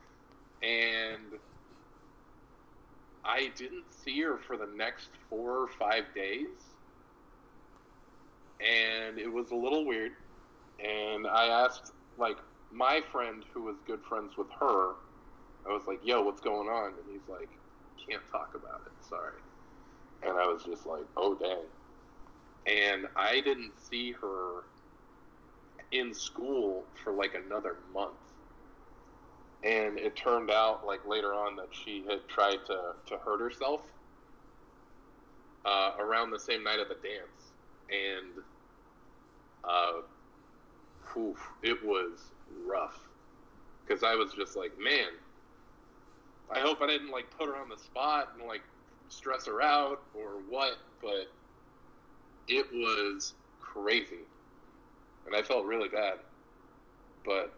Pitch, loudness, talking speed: 140 Hz, -33 LUFS, 130 wpm